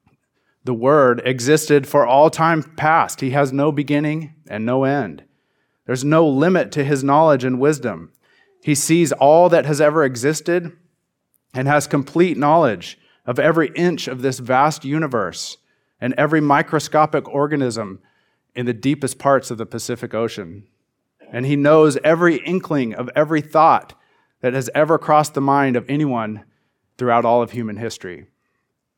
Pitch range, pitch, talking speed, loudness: 125-155 Hz, 145 Hz, 150 wpm, -17 LUFS